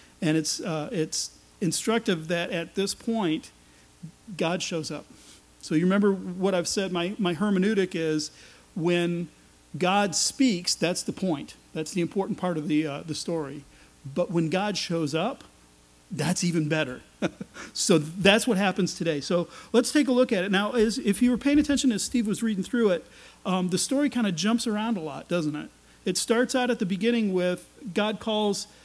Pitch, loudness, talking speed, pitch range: 185 Hz, -26 LUFS, 185 wpm, 160-210 Hz